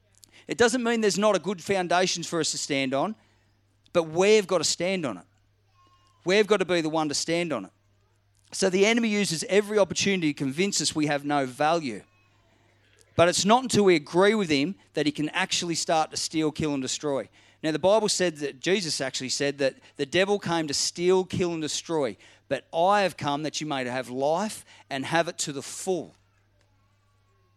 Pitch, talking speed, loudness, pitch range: 155 Hz, 200 wpm, -25 LUFS, 120-185 Hz